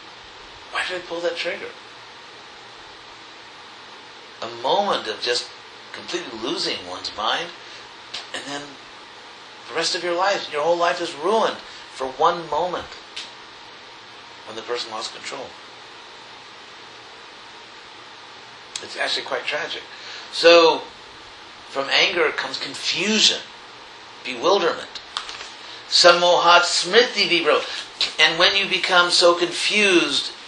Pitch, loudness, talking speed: 190 Hz, -19 LUFS, 105 wpm